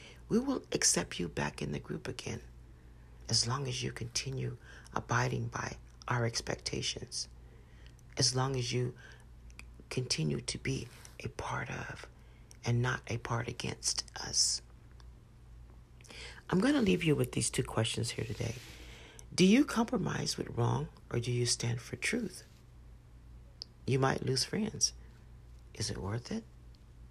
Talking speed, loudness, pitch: 140 wpm, -34 LUFS, 115 Hz